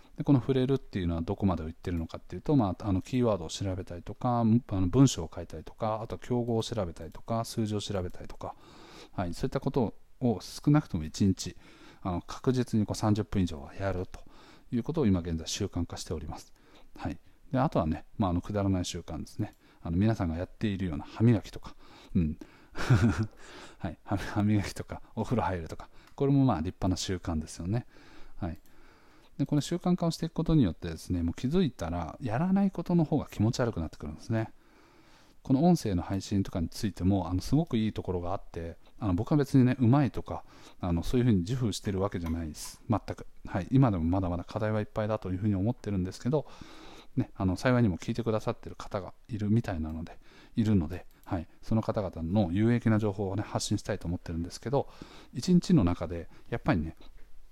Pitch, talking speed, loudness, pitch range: 105 Hz, 430 characters per minute, -30 LUFS, 90-120 Hz